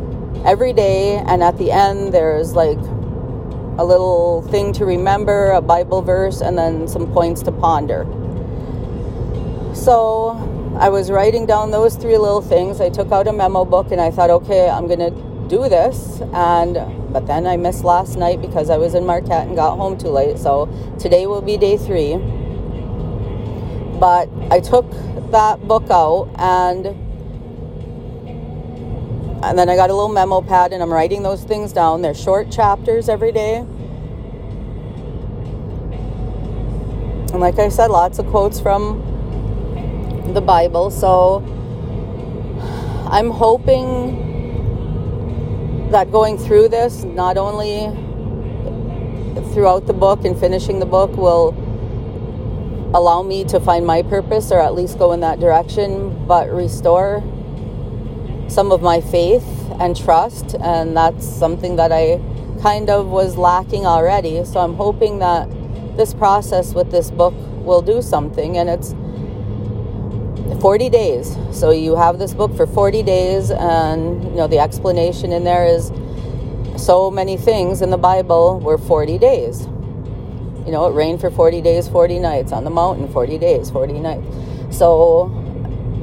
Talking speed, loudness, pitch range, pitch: 145 wpm, -16 LUFS, 125-195 Hz, 175 Hz